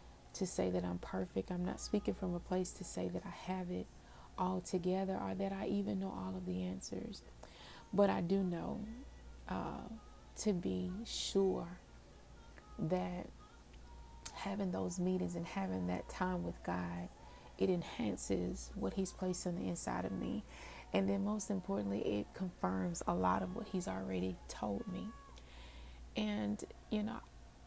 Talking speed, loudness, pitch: 160 wpm, -40 LUFS, 105 Hz